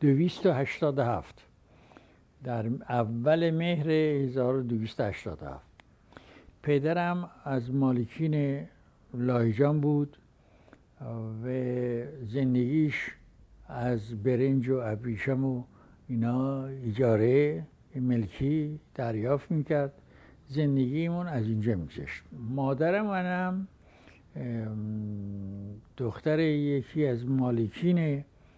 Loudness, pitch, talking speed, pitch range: -30 LUFS, 130 Hz, 65 wpm, 115-150 Hz